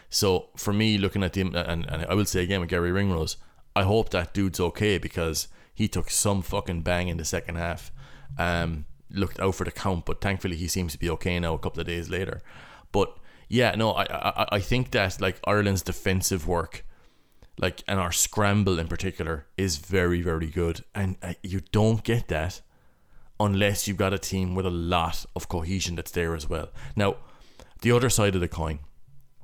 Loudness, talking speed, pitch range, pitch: -27 LUFS, 200 wpm, 85-100 Hz, 95 Hz